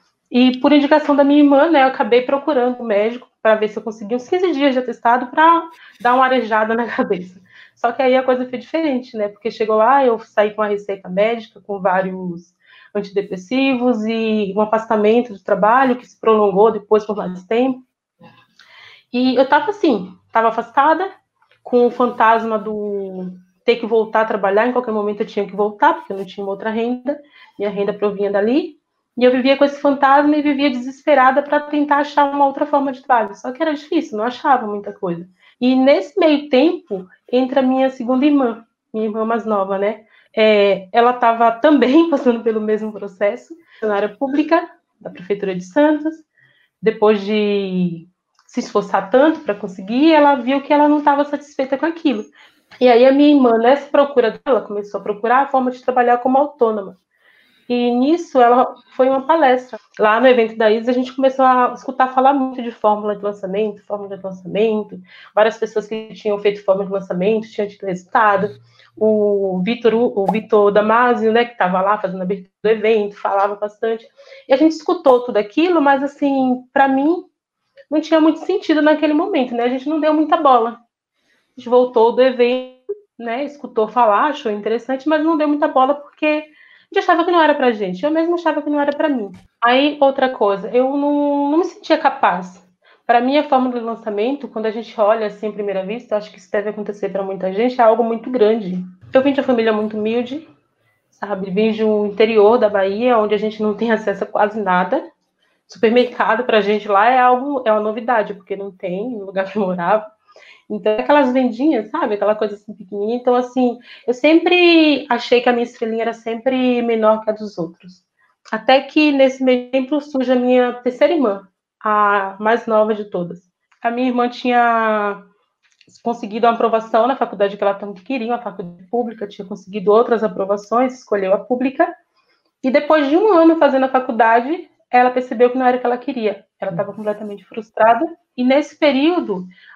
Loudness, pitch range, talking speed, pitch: -16 LUFS, 210-275 Hz, 190 wpm, 235 Hz